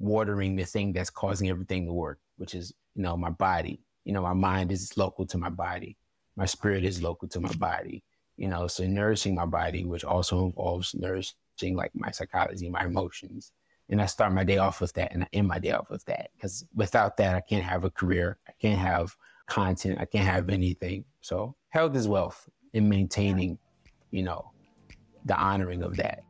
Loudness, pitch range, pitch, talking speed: -29 LUFS, 90-100 Hz, 95 Hz, 205 wpm